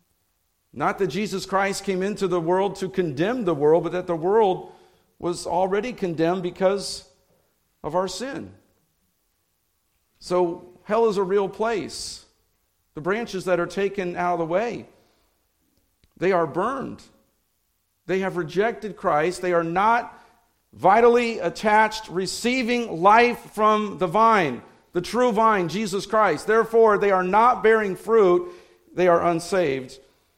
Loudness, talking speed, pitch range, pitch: -22 LUFS, 135 wpm, 175-220 Hz, 190 Hz